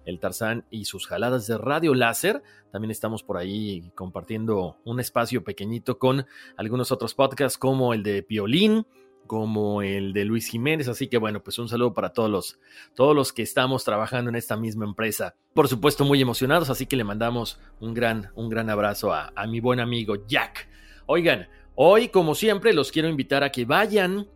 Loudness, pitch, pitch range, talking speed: -24 LUFS, 120 Hz, 110-130 Hz, 185 wpm